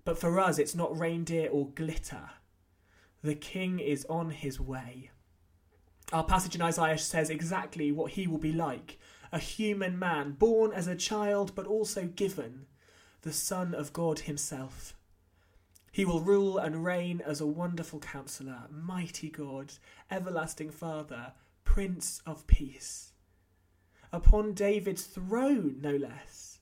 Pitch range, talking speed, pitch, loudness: 135-180 Hz, 140 wpm, 160 Hz, -33 LUFS